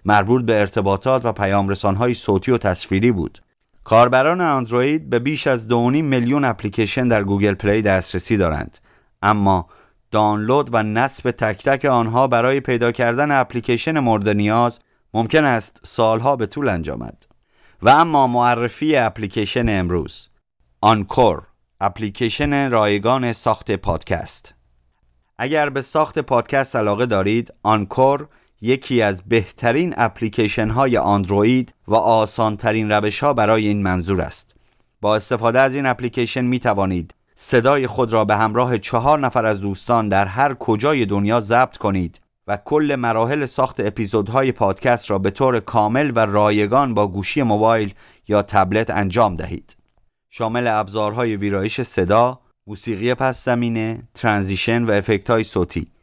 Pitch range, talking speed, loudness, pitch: 105-125 Hz, 135 wpm, -18 LUFS, 115 Hz